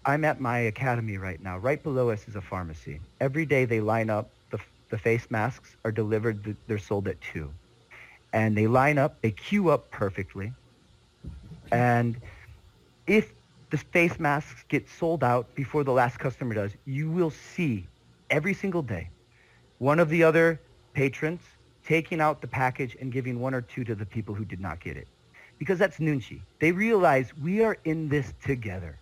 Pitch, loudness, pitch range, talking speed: 125 Hz, -27 LUFS, 105-150 Hz, 180 wpm